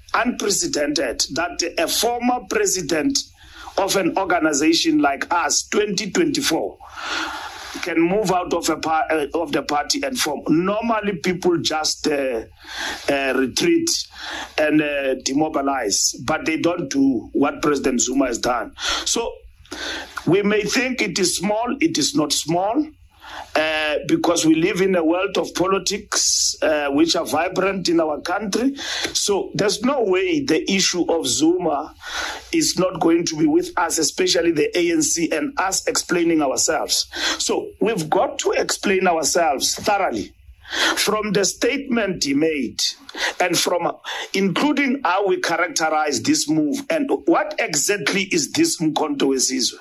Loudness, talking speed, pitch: -20 LUFS, 140 wpm, 235 Hz